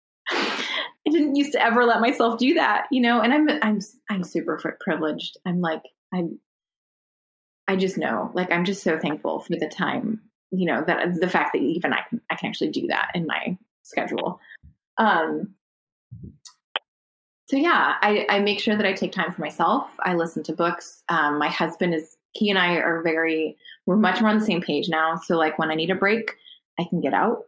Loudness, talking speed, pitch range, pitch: -23 LUFS, 205 wpm, 165-220 Hz, 185 Hz